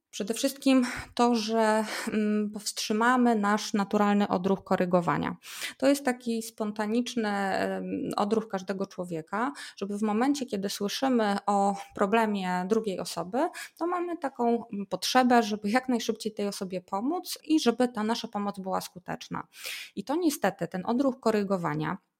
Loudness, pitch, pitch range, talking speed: -28 LUFS, 215 Hz, 200-245 Hz, 130 wpm